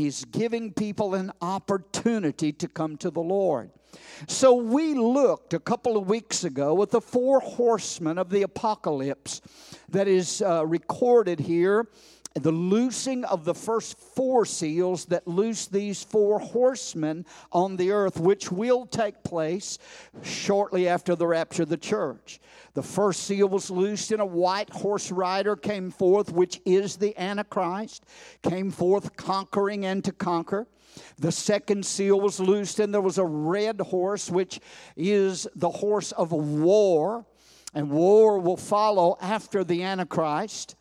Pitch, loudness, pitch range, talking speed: 195 Hz, -25 LUFS, 175-210 Hz, 150 wpm